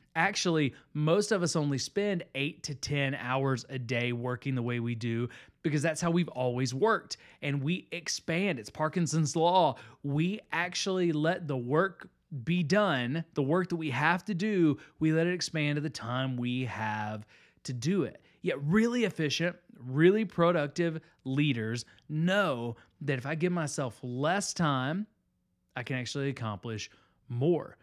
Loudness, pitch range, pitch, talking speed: -31 LUFS, 130-175 Hz, 155 Hz, 160 wpm